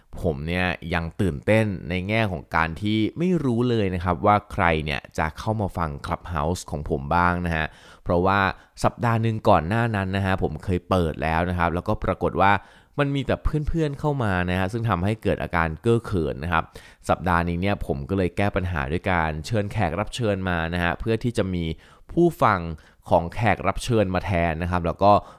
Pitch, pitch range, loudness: 90 Hz, 85-105 Hz, -24 LUFS